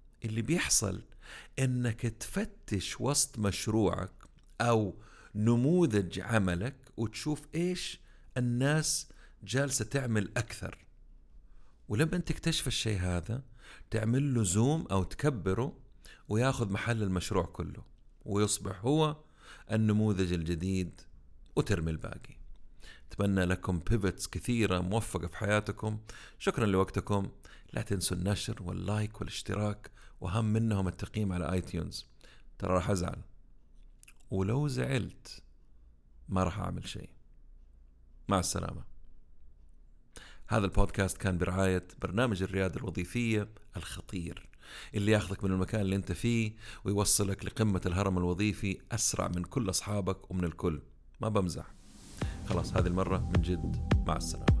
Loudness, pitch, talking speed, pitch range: -32 LUFS, 100 Hz, 110 wpm, 90-115 Hz